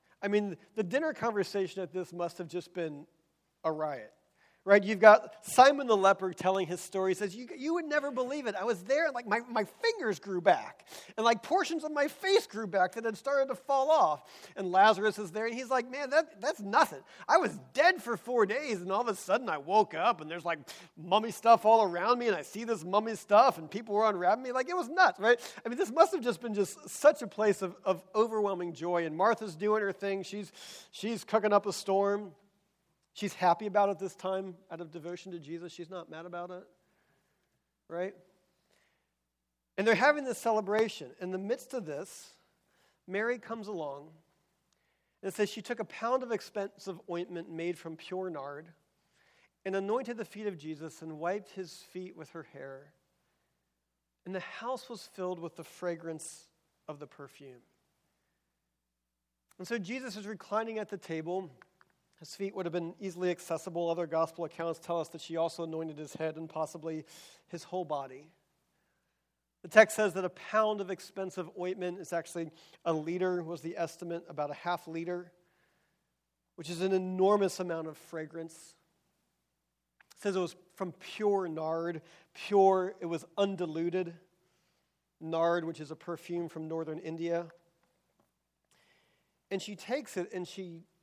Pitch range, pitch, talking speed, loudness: 165-215 Hz, 185 Hz, 185 wpm, -31 LUFS